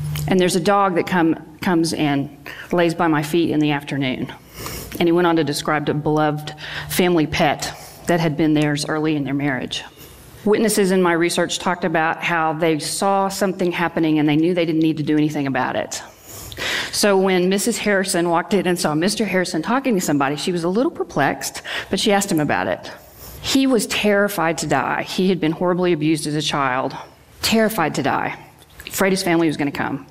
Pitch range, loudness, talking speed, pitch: 155-190 Hz, -19 LUFS, 205 wpm, 170 Hz